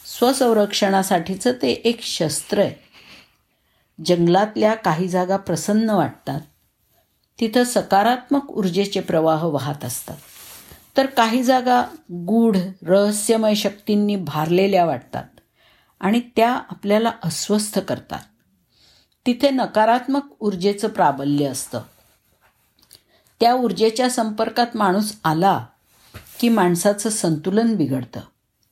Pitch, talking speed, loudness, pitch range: 205 Hz, 90 wpm, -20 LUFS, 180-230 Hz